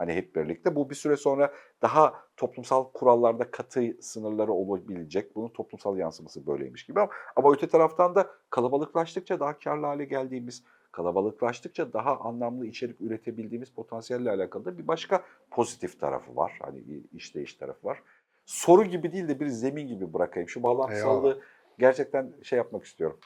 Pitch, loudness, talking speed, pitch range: 130 Hz, -28 LUFS, 150 wpm, 115-145 Hz